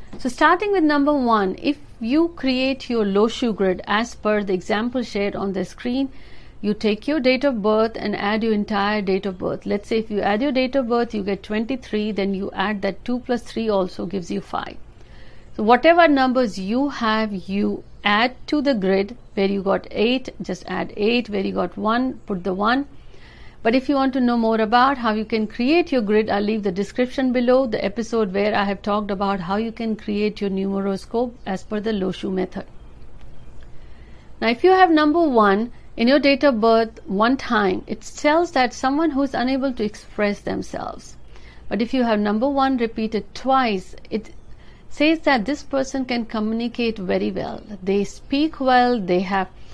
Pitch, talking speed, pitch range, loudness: 225 Hz, 195 wpm, 200-260 Hz, -21 LUFS